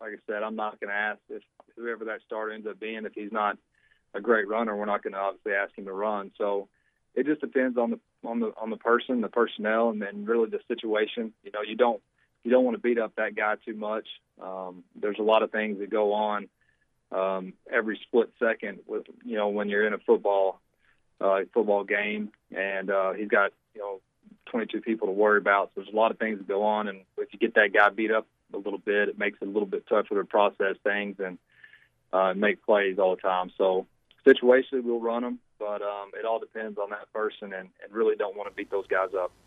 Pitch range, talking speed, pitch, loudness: 100-115 Hz, 240 wpm, 105 Hz, -27 LUFS